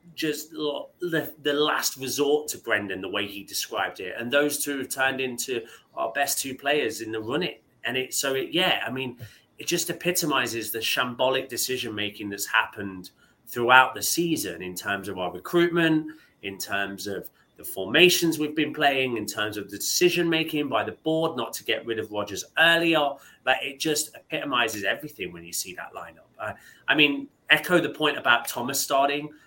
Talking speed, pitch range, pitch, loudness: 190 wpm, 110-150 Hz, 135 Hz, -25 LUFS